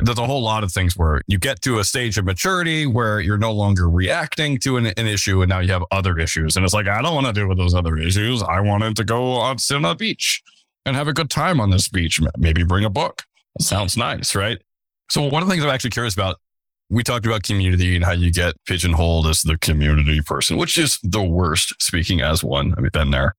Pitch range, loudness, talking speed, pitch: 90-120 Hz, -19 LUFS, 250 wpm, 100 Hz